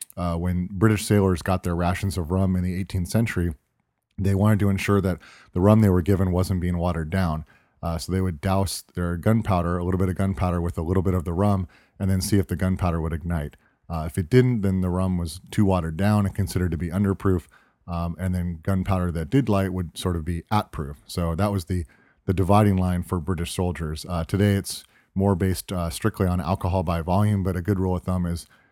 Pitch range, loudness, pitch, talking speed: 85-100 Hz, -24 LUFS, 95 Hz, 230 wpm